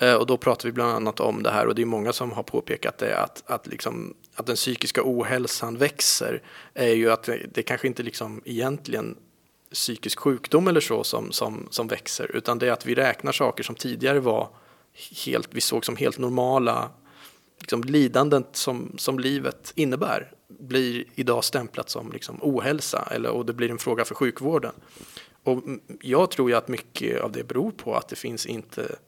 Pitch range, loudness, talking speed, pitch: 115-130 Hz, -25 LUFS, 190 wpm, 125 Hz